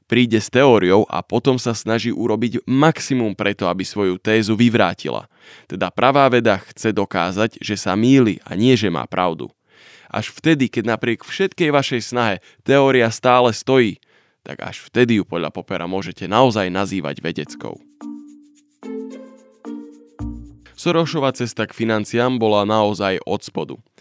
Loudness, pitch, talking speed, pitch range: -18 LUFS, 115 Hz, 135 wpm, 100-130 Hz